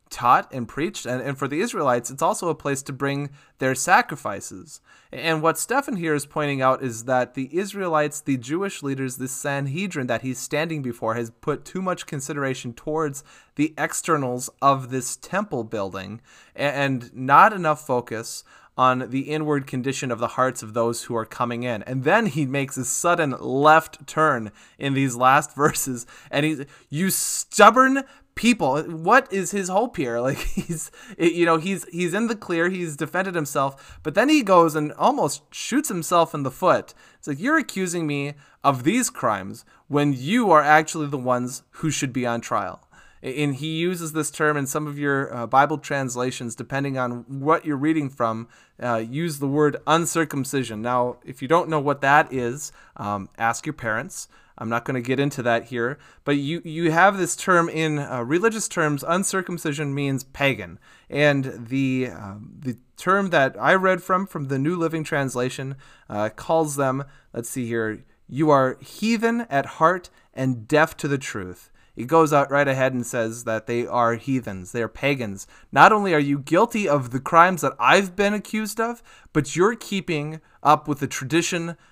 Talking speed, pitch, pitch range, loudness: 180 wpm, 145 Hz, 130-165 Hz, -22 LUFS